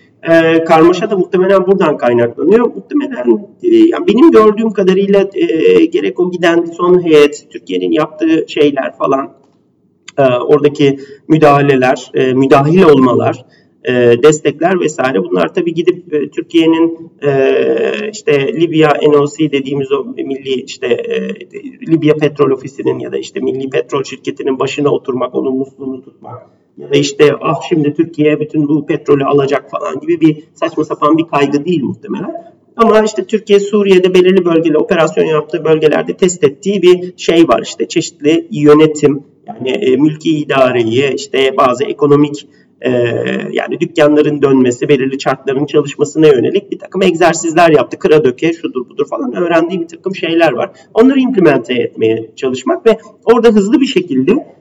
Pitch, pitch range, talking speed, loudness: 160 Hz, 145-195 Hz, 140 wpm, -11 LUFS